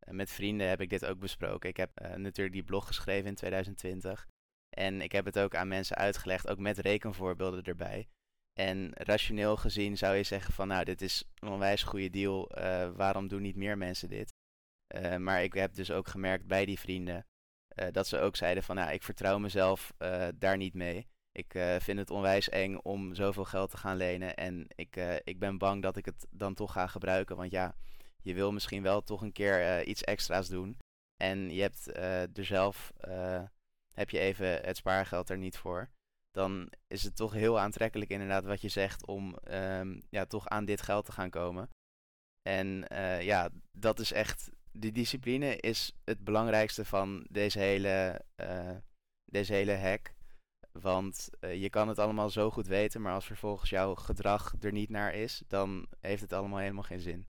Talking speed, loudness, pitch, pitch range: 200 wpm, -35 LUFS, 95 Hz, 95-100 Hz